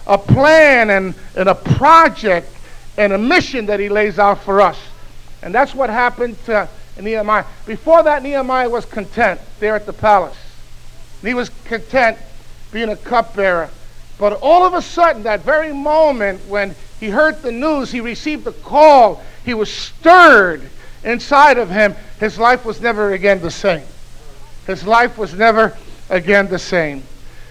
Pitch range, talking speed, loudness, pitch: 200-270 Hz, 160 wpm, -13 LUFS, 220 Hz